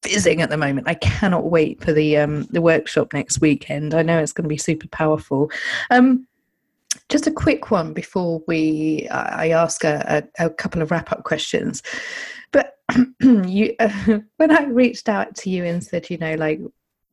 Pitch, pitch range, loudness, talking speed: 170 Hz, 155-230 Hz, -19 LUFS, 180 wpm